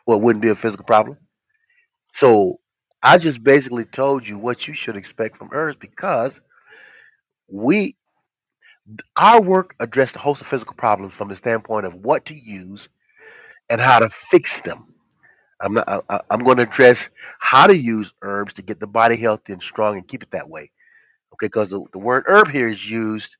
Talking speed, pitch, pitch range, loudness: 185 wpm, 120 Hz, 110-175 Hz, -17 LUFS